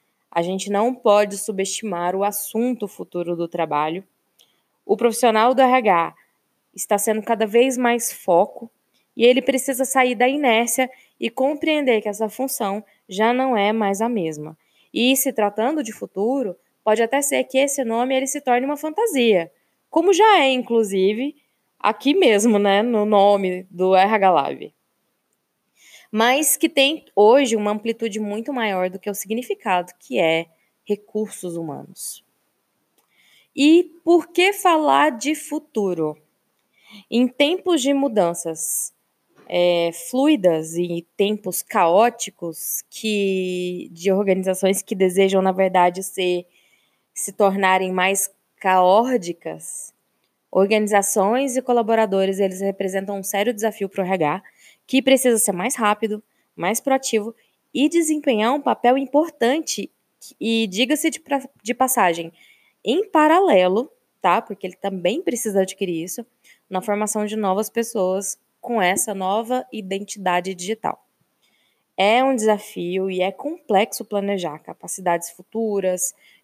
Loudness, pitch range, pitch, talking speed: -20 LUFS, 190-255 Hz, 215 Hz, 130 wpm